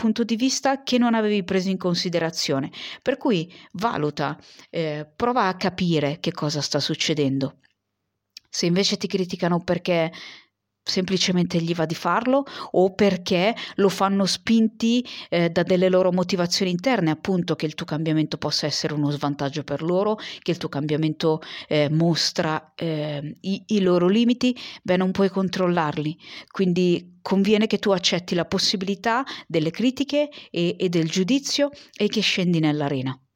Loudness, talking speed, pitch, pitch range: -23 LUFS, 150 wpm, 180 Hz, 155-205 Hz